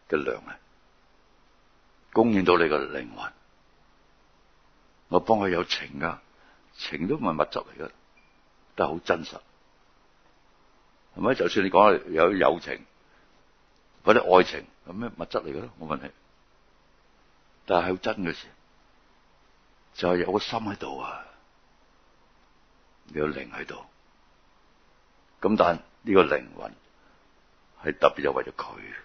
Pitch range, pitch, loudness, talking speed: 85-105 Hz, 90 Hz, -26 LUFS, 170 characters per minute